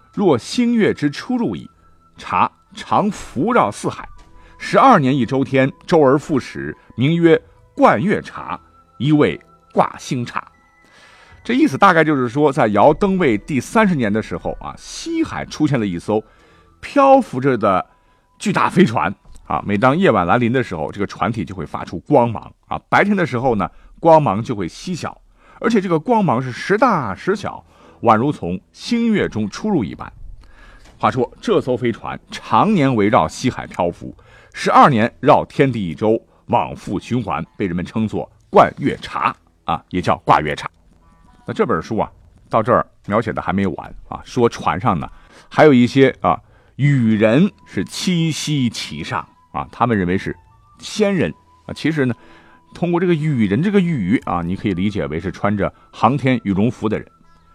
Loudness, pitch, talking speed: -17 LUFS, 130 Hz, 240 characters per minute